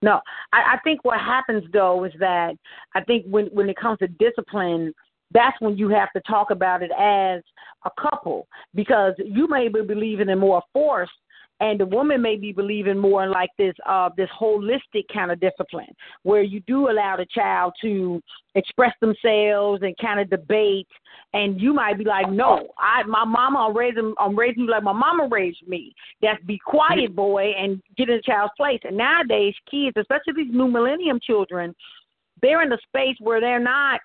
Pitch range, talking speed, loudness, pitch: 195-245 Hz, 195 wpm, -21 LUFS, 210 Hz